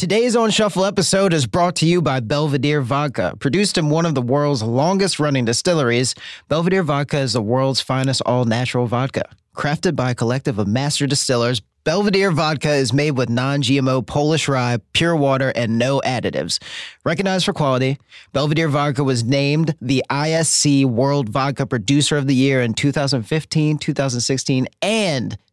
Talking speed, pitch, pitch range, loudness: 160 wpm, 140 Hz, 130-155 Hz, -18 LUFS